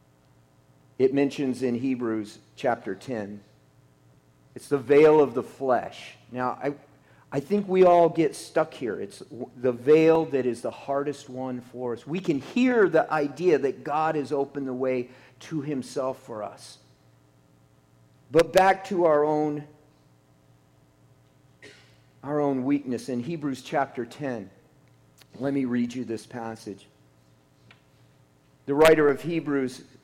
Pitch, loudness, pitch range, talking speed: 130 Hz, -25 LUFS, 105-150 Hz, 135 wpm